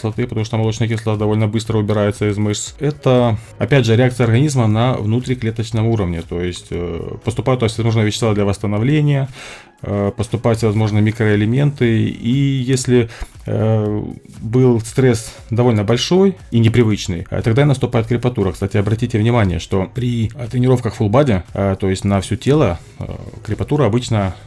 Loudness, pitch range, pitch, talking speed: -17 LUFS, 105-125 Hz, 115 Hz, 140 wpm